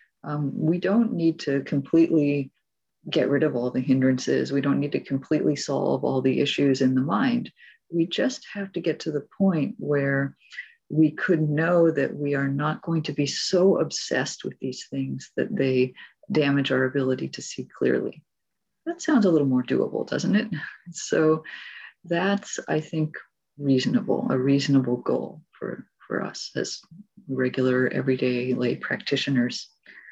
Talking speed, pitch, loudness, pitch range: 160 wpm, 145 Hz, -24 LUFS, 130-170 Hz